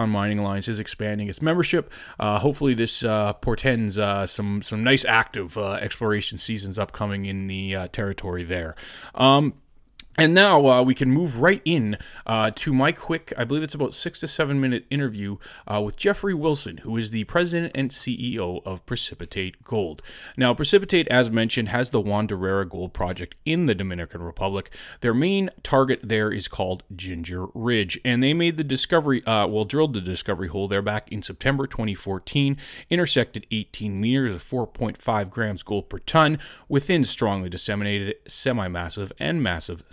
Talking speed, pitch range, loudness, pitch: 170 wpm, 100-135 Hz, -23 LUFS, 110 Hz